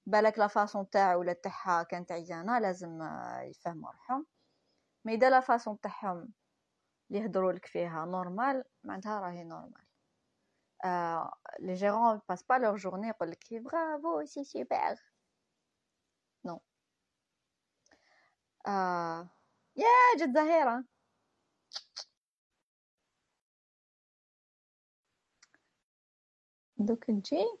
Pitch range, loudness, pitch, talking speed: 180-250 Hz, -32 LUFS, 210 Hz, 90 wpm